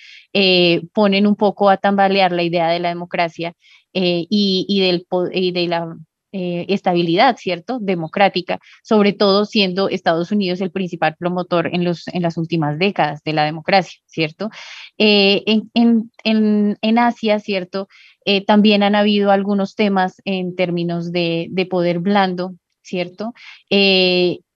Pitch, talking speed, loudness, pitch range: 185 Hz, 150 wpm, -17 LUFS, 175-205 Hz